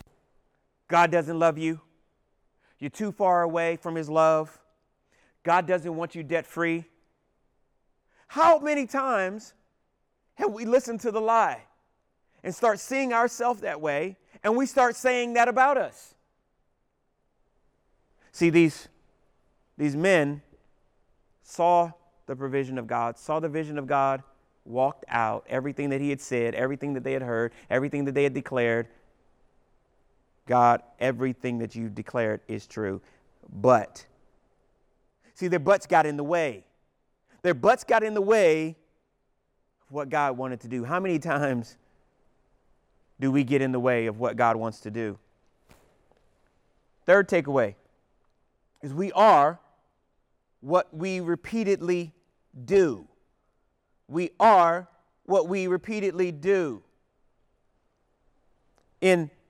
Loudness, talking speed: -25 LUFS, 130 wpm